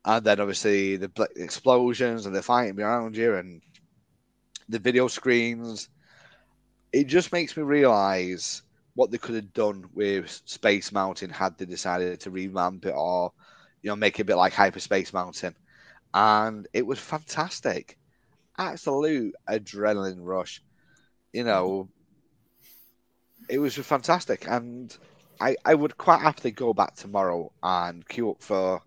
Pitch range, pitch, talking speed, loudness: 95-120 Hz, 105 Hz, 140 wpm, -26 LUFS